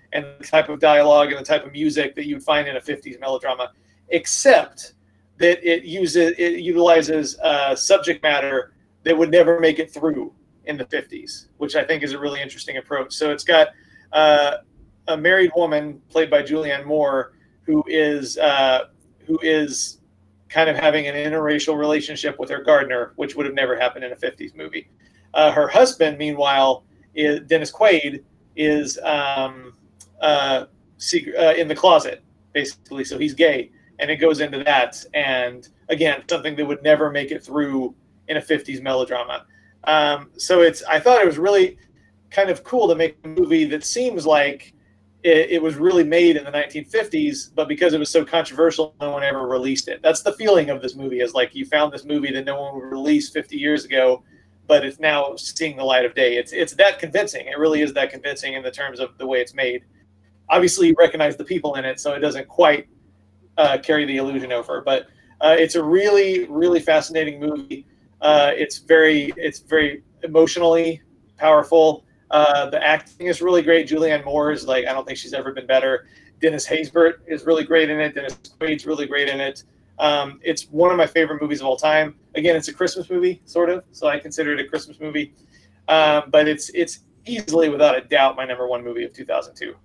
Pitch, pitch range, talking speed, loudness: 150 Hz, 135-165 Hz, 195 wpm, -19 LUFS